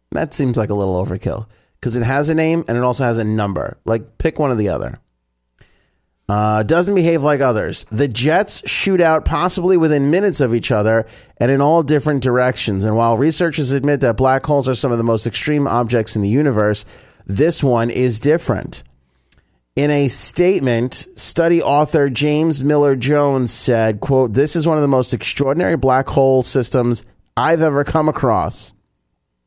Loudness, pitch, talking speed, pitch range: -16 LUFS, 130 Hz, 180 wpm, 110-150 Hz